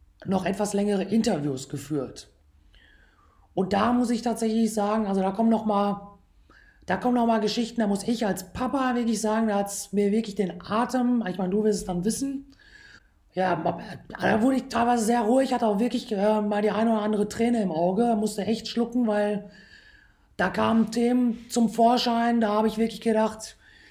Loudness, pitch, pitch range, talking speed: -25 LUFS, 220 Hz, 200-235 Hz, 185 wpm